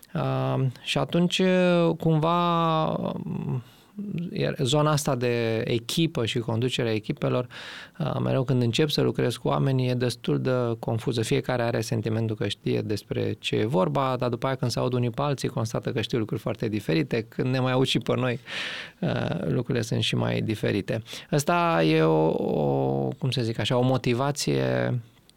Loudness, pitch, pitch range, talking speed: -26 LUFS, 125 Hz, 115-145 Hz, 165 wpm